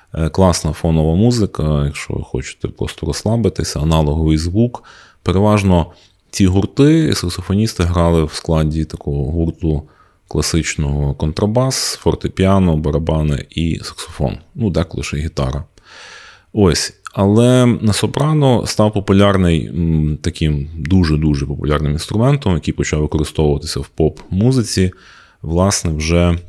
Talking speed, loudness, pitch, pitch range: 105 wpm, -16 LUFS, 85 Hz, 75-100 Hz